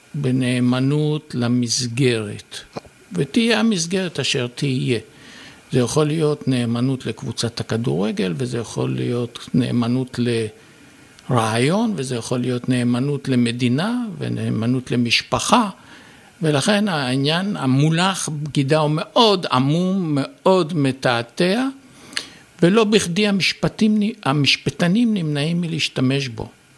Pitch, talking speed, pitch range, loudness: 140 Hz, 90 wpm, 125-175 Hz, -20 LUFS